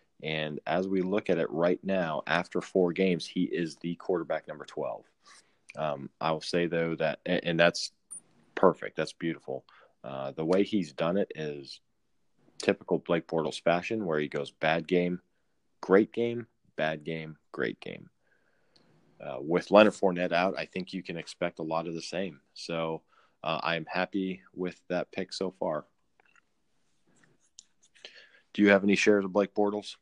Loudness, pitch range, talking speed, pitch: -30 LUFS, 80-95 Hz, 165 wpm, 85 Hz